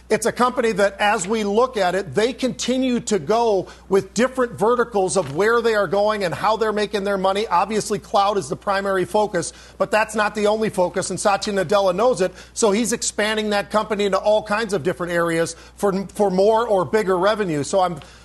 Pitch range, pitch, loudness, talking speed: 190-215 Hz, 205 Hz, -20 LUFS, 205 wpm